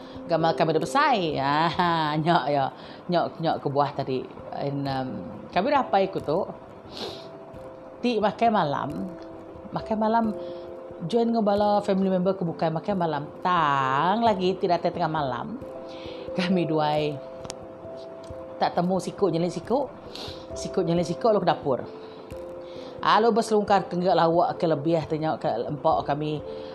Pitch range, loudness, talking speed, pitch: 145-190 Hz, -25 LUFS, 140 wpm, 170 Hz